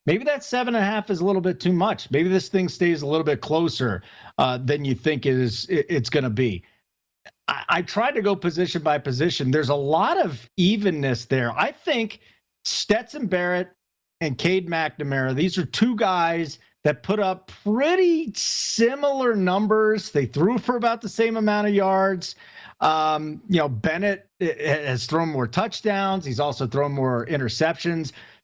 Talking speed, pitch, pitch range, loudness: 175 wpm, 170 Hz, 145-200 Hz, -23 LUFS